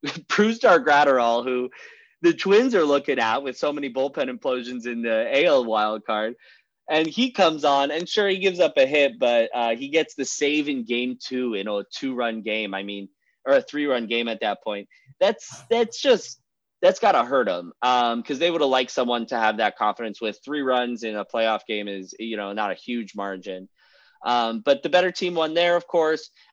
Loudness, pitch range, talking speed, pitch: -23 LUFS, 115-160 Hz, 210 wpm, 125 Hz